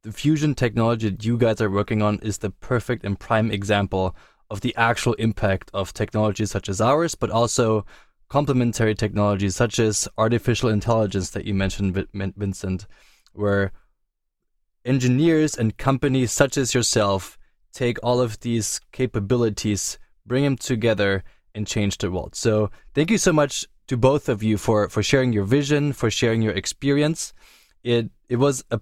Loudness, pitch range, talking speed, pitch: -22 LUFS, 100-125 Hz, 160 wpm, 110 Hz